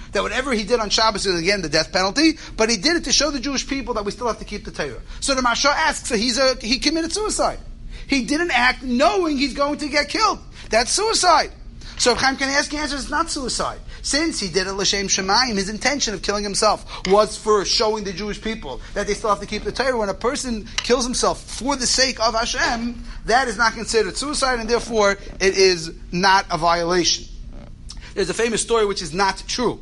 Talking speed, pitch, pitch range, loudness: 225 wpm, 230 Hz, 205-275 Hz, -20 LUFS